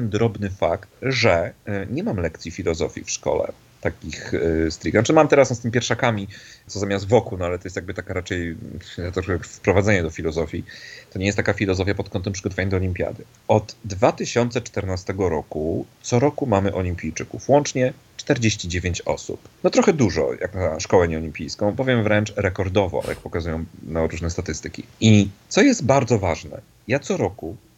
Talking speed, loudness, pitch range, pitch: 160 wpm, -22 LUFS, 90-115 Hz, 100 Hz